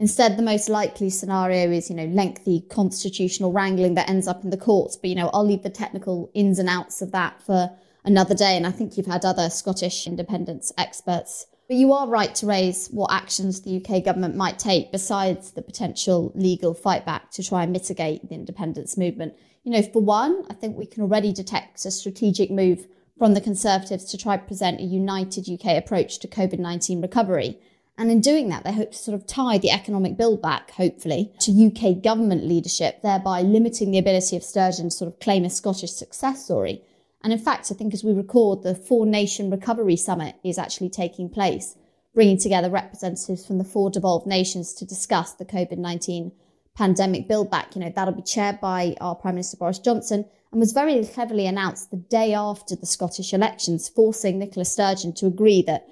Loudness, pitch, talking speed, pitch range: -23 LUFS, 190 Hz, 200 wpm, 180-210 Hz